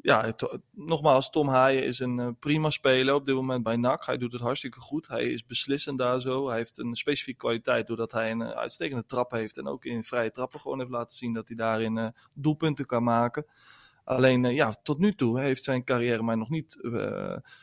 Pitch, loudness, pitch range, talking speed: 125 Hz, -28 LUFS, 115-140 Hz, 225 wpm